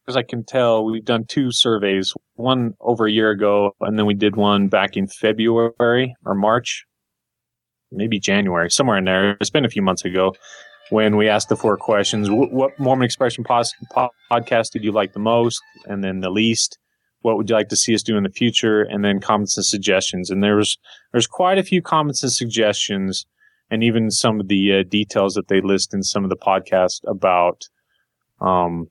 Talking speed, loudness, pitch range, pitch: 200 wpm, -18 LUFS, 100-120 Hz, 110 Hz